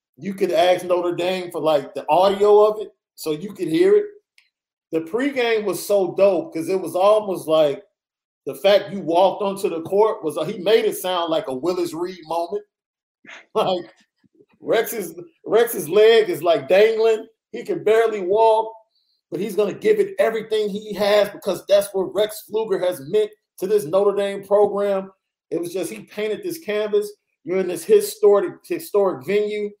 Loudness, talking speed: -20 LUFS, 175 wpm